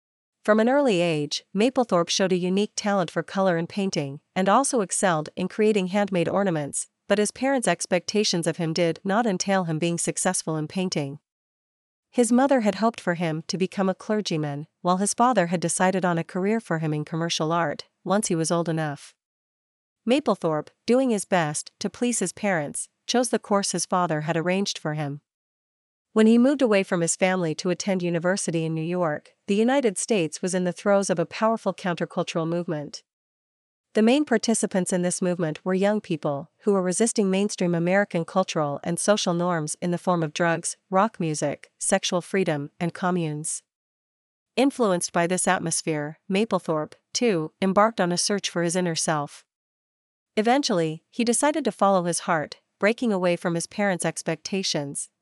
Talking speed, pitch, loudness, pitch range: 175 wpm, 185 Hz, -24 LUFS, 165-205 Hz